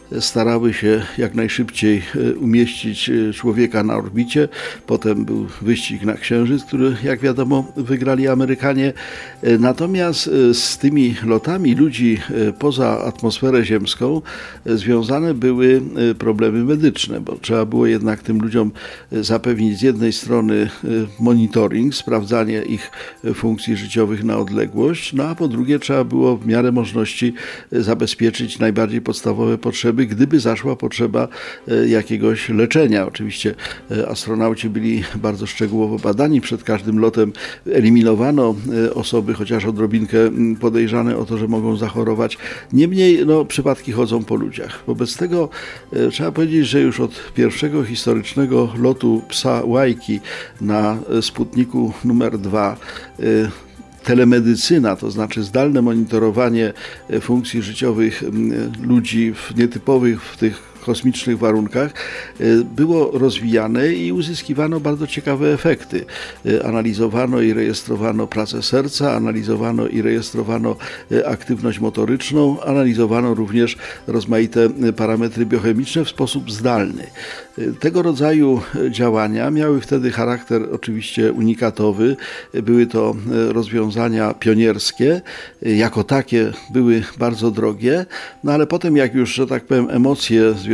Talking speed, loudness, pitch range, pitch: 115 wpm, -17 LUFS, 110-130 Hz, 115 Hz